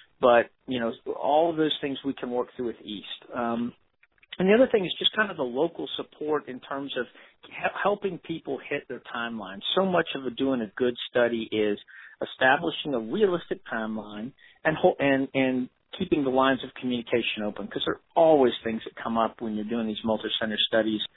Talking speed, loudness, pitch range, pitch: 200 wpm, -27 LUFS, 115-150 Hz, 125 Hz